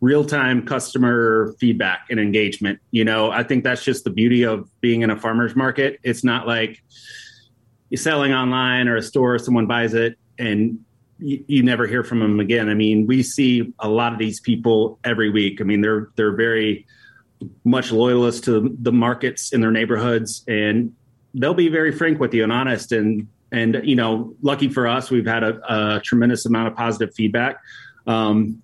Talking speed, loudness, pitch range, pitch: 190 wpm, -19 LUFS, 110-125 Hz, 115 Hz